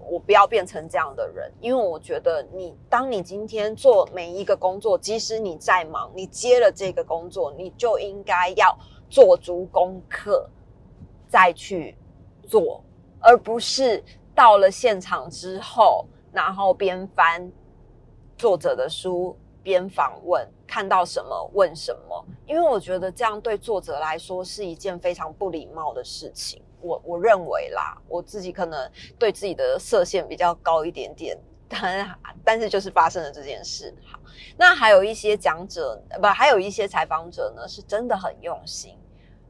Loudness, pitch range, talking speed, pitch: -21 LUFS, 175-230 Hz, 235 characters per minute, 190 Hz